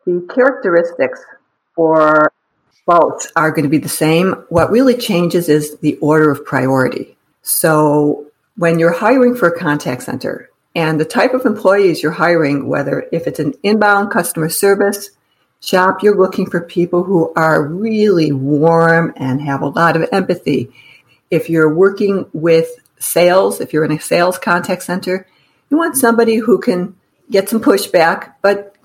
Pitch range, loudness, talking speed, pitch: 155-200 Hz, -14 LUFS, 160 wpm, 170 Hz